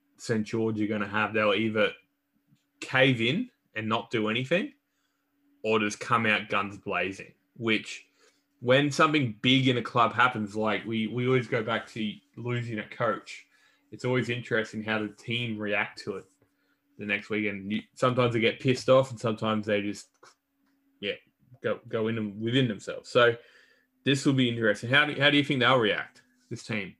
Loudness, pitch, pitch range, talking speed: -27 LUFS, 115 Hz, 110-135 Hz, 180 wpm